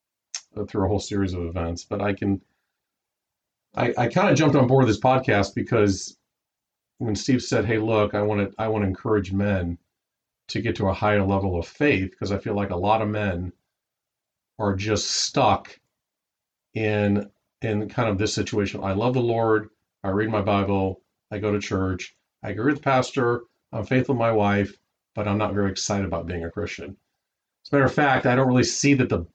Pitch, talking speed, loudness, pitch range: 105 Hz, 200 wpm, -23 LUFS, 95-115 Hz